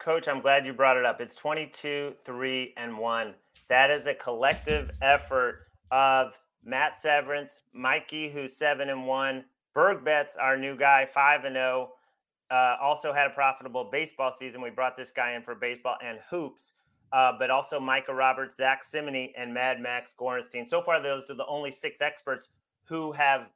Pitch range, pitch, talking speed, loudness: 130-145 Hz, 135 Hz, 180 wpm, -27 LUFS